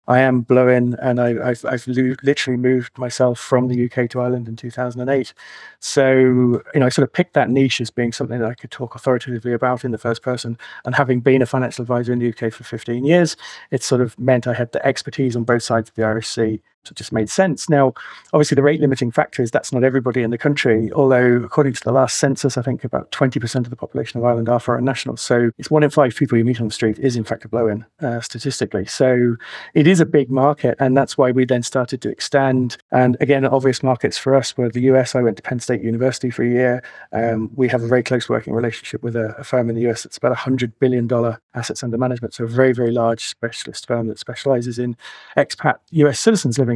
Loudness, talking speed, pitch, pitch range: -18 LUFS, 240 wpm, 125 Hz, 120-135 Hz